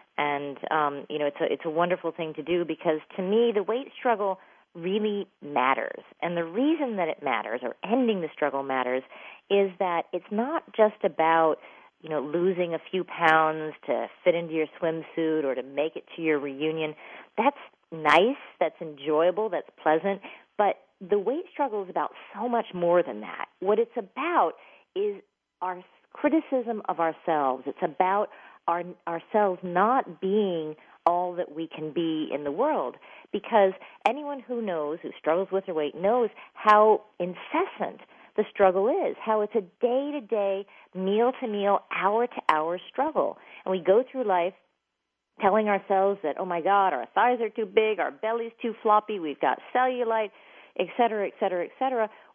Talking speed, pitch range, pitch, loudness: 170 wpm, 165-220 Hz, 185 Hz, -27 LUFS